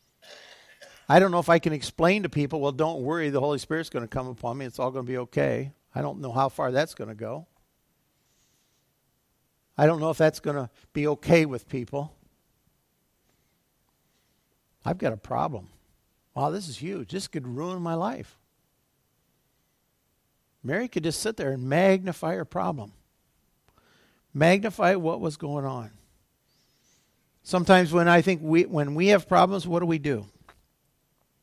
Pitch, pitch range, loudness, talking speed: 155 Hz, 135-170 Hz, -25 LUFS, 155 wpm